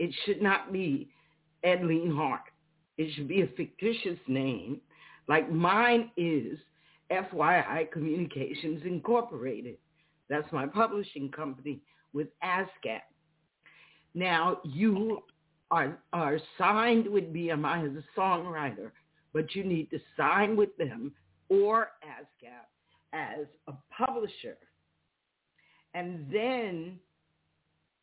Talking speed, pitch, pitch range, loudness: 105 wpm, 165 Hz, 150-195 Hz, -30 LUFS